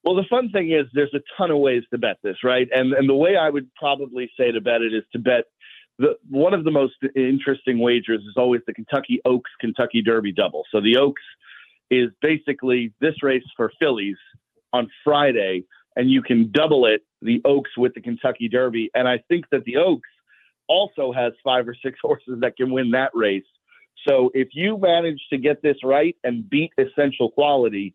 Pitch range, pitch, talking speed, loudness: 120-145 Hz, 130 Hz, 200 wpm, -21 LUFS